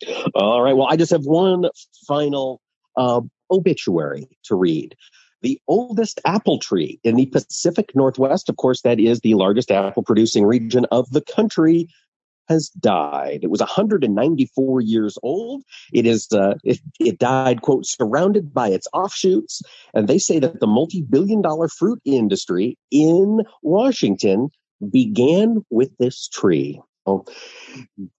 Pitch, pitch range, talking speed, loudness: 155 Hz, 125-210 Hz, 135 wpm, -18 LUFS